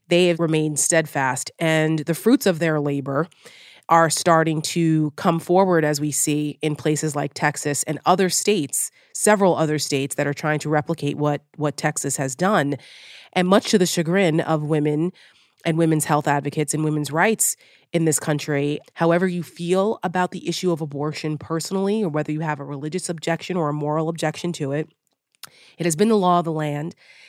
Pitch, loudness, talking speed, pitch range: 160 Hz, -21 LUFS, 185 wpm, 150-175 Hz